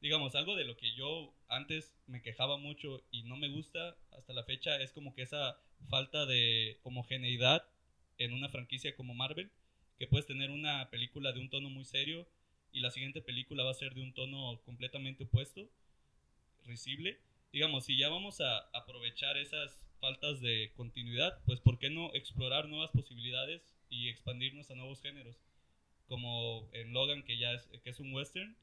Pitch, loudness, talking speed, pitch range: 130 Hz, -37 LUFS, 175 wpm, 120-145 Hz